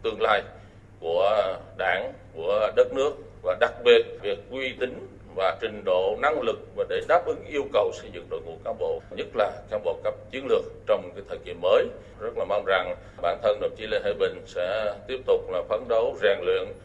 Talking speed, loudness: 215 wpm, -26 LUFS